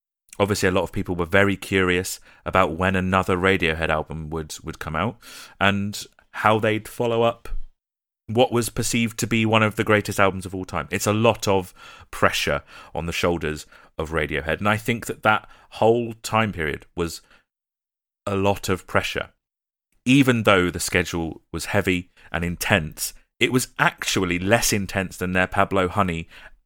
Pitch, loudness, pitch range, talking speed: 95 Hz, -22 LUFS, 90-110 Hz, 170 wpm